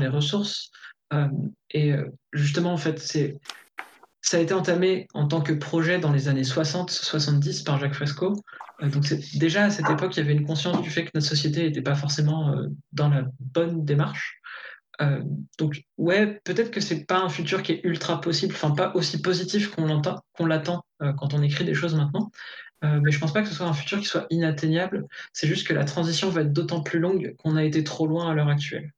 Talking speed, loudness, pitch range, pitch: 225 wpm, -25 LUFS, 150-175 Hz, 160 Hz